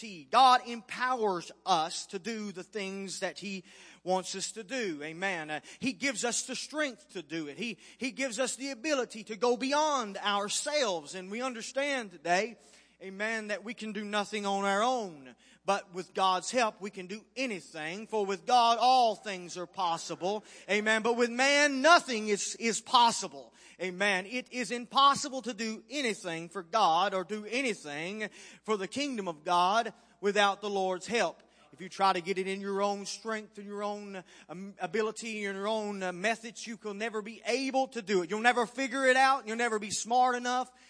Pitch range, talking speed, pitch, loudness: 190-245 Hz, 185 wpm, 215 Hz, -31 LUFS